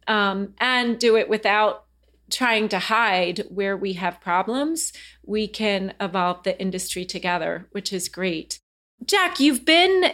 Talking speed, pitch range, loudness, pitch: 140 wpm, 185-235 Hz, -22 LUFS, 200 Hz